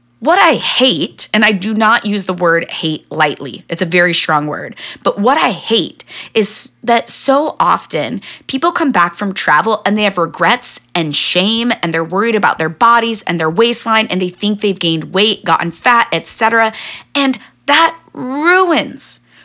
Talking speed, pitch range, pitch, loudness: 175 wpm, 170-235 Hz, 210 Hz, -13 LUFS